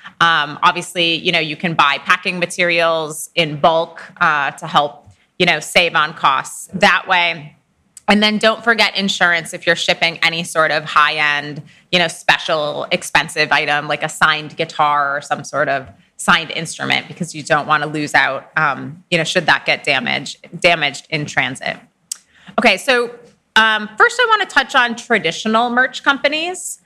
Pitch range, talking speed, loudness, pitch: 150-200 Hz, 170 wpm, -15 LUFS, 170 Hz